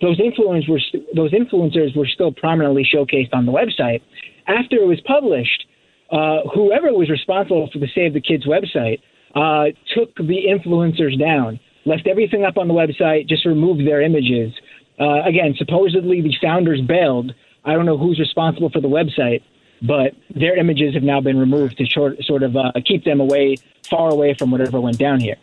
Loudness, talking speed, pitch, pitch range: -17 LUFS, 185 wpm, 155 Hz, 140-175 Hz